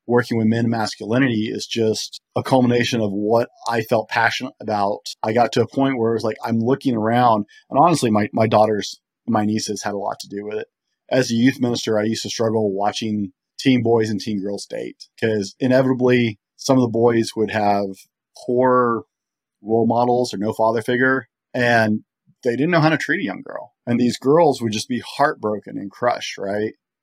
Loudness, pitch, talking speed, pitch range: -20 LUFS, 115 Hz, 205 wpm, 105-125 Hz